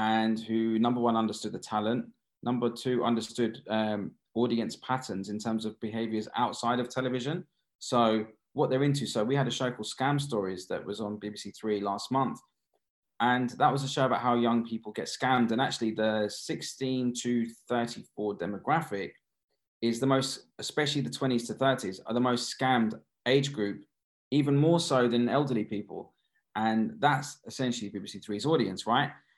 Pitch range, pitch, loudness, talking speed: 110-130 Hz, 120 Hz, -30 LUFS, 170 wpm